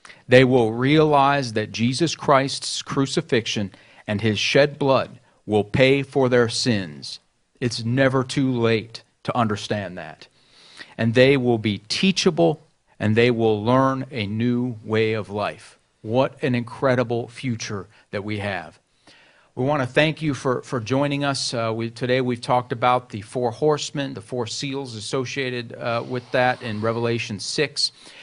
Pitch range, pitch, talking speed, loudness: 115-135 Hz, 125 Hz, 155 wpm, -22 LUFS